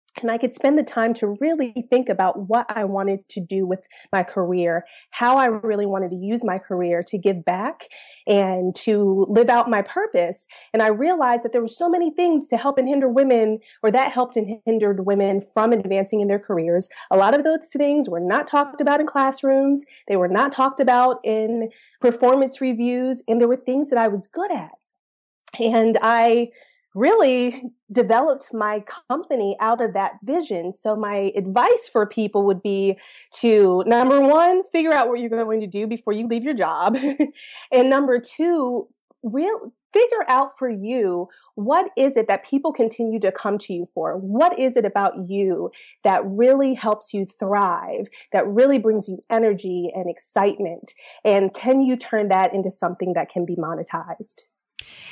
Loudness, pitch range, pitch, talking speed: -20 LUFS, 200-265 Hz, 230 Hz, 180 wpm